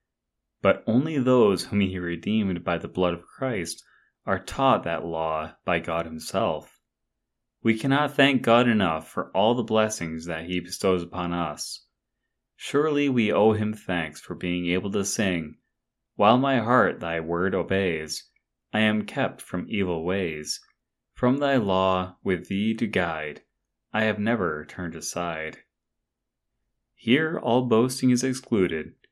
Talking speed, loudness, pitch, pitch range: 145 wpm, -25 LUFS, 95 Hz, 85-115 Hz